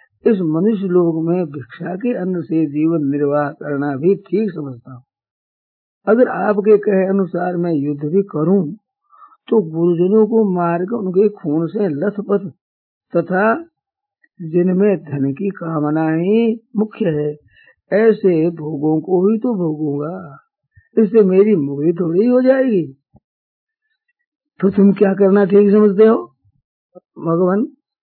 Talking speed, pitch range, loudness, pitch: 125 wpm, 155-215 Hz, -16 LUFS, 185 Hz